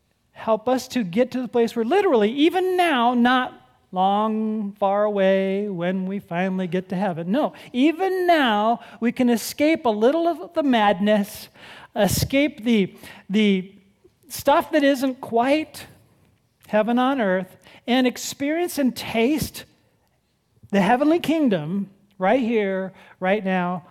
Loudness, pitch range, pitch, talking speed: -21 LUFS, 195-270 Hz, 230 Hz, 135 wpm